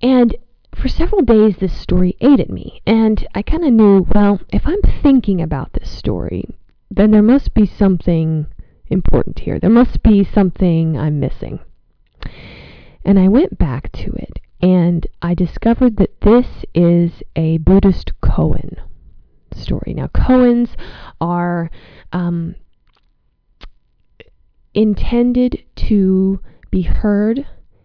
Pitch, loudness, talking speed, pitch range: 195 Hz, -15 LUFS, 125 wpm, 170-230 Hz